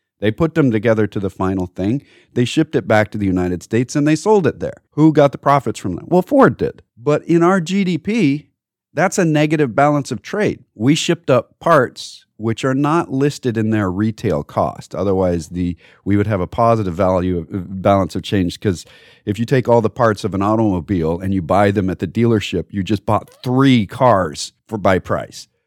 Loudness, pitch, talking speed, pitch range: -17 LUFS, 110 Hz, 210 wpm, 95-145 Hz